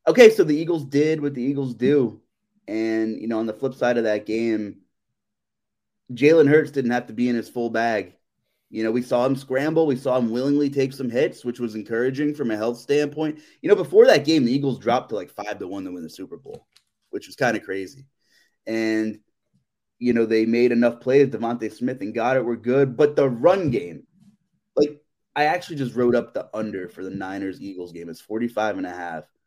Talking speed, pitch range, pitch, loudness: 220 wpm, 110-145 Hz, 125 Hz, -22 LUFS